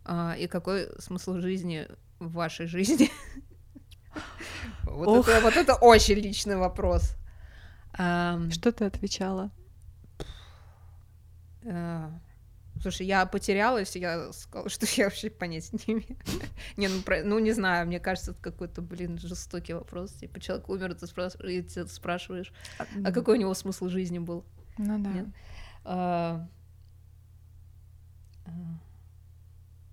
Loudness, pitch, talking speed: -28 LUFS, 175 Hz, 100 wpm